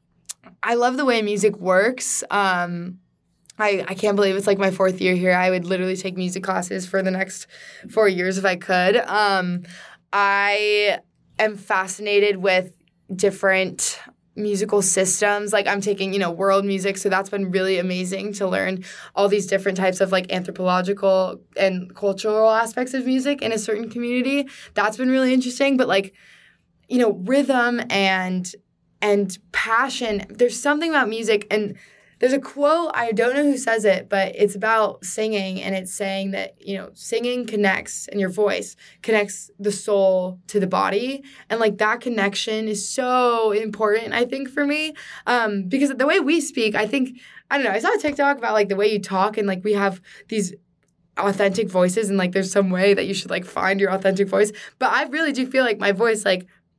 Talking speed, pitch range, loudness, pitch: 185 wpm, 190-225 Hz, -21 LUFS, 205 Hz